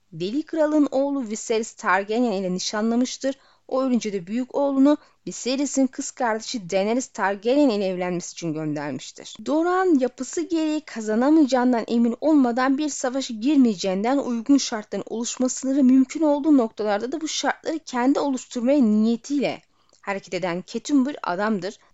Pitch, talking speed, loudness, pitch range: 250 Hz, 130 wpm, -23 LUFS, 215-280 Hz